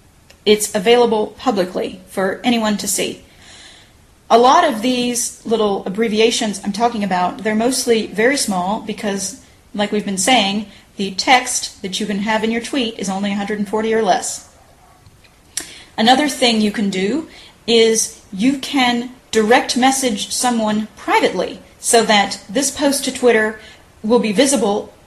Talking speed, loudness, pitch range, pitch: 145 wpm, -16 LUFS, 205-250 Hz, 220 Hz